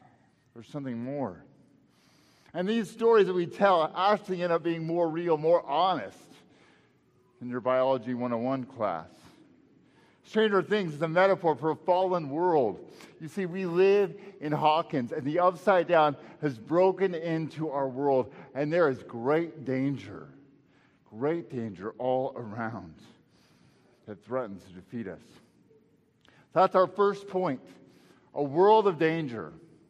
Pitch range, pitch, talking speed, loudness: 130-185 Hz, 155 Hz, 140 wpm, -28 LUFS